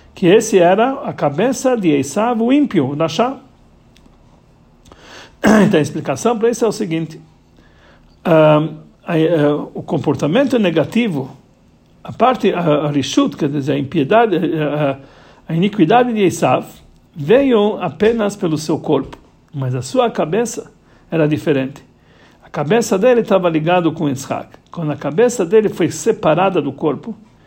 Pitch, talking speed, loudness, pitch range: 170 Hz, 140 wpm, -16 LUFS, 150-225 Hz